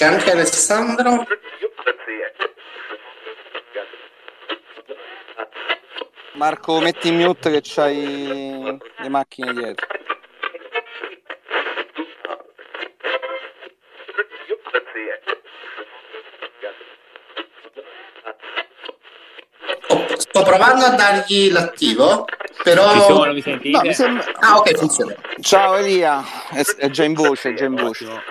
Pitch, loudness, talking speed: 210 Hz, -17 LUFS, 70 wpm